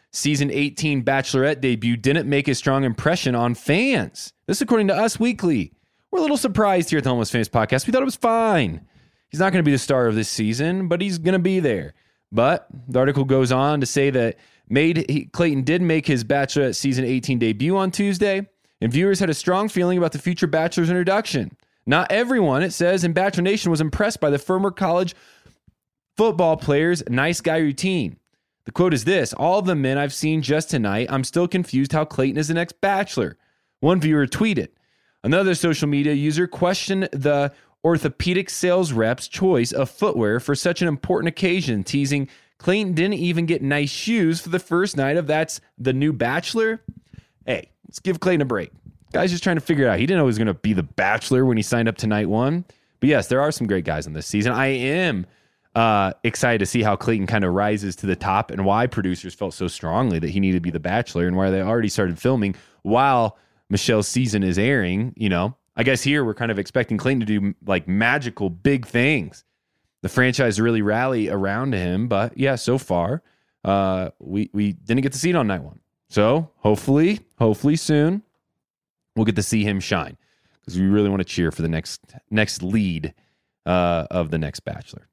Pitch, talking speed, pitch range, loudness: 135 Hz, 205 wpm, 110-170 Hz, -21 LUFS